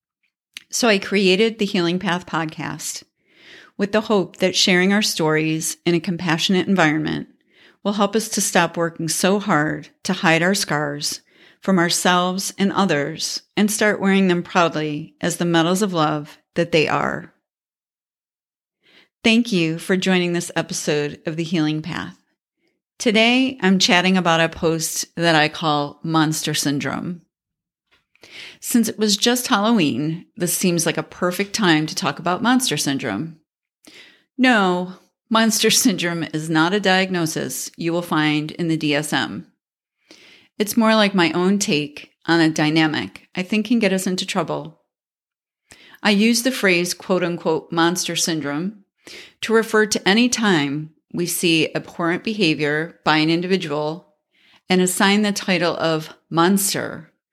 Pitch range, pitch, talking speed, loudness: 160-200 Hz, 175 Hz, 145 wpm, -19 LUFS